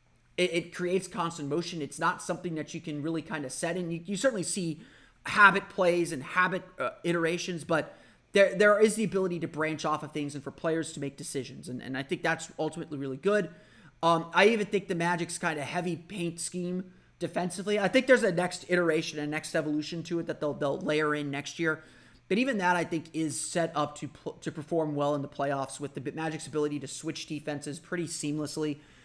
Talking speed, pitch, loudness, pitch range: 220 wpm, 165 Hz, -30 LUFS, 150-180 Hz